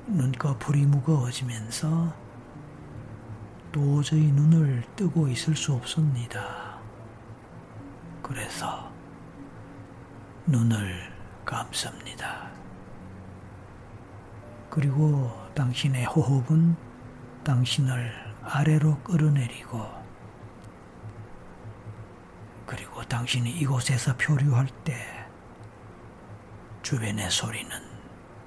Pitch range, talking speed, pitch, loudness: 115-145 Hz, 155 characters per minute, 125 Hz, -26 LUFS